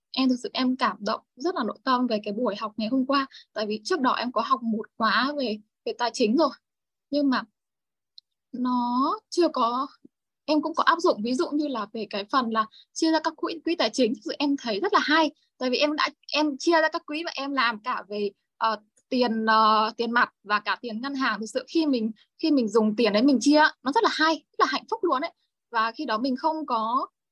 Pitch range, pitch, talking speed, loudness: 225-310 Hz, 260 Hz, 250 wpm, -25 LUFS